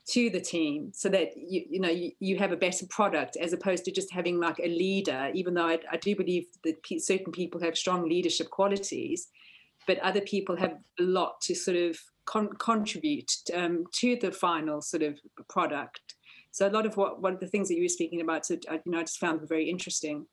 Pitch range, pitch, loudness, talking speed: 170-195 Hz, 180 Hz, -30 LUFS, 220 wpm